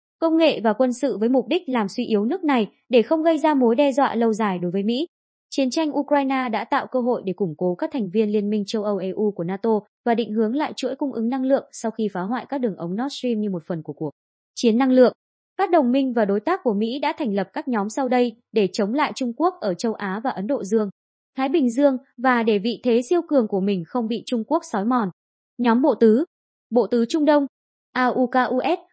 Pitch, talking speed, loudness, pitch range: 245 Hz, 255 wpm, -22 LUFS, 215-275 Hz